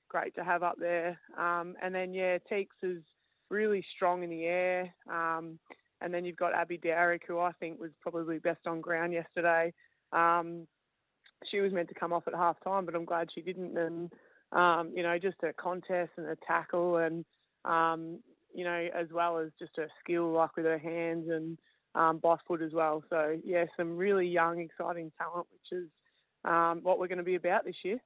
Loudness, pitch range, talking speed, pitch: -33 LUFS, 165-175 Hz, 205 wpm, 170 Hz